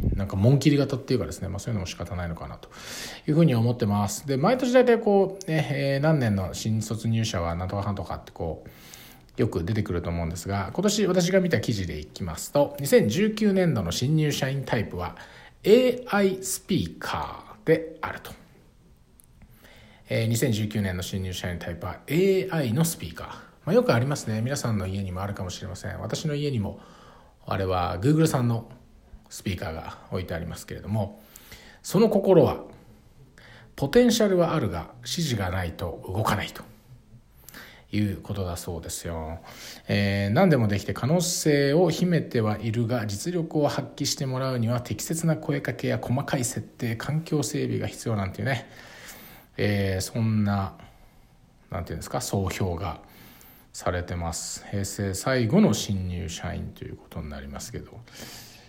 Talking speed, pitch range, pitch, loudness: 330 characters per minute, 100-150 Hz, 115 Hz, -26 LUFS